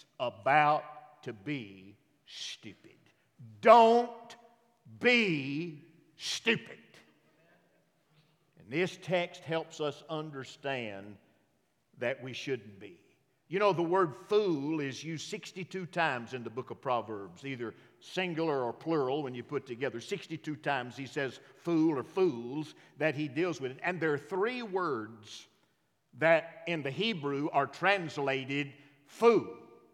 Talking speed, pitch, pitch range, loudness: 125 wpm, 150 Hz, 130-170 Hz, -32 LUFS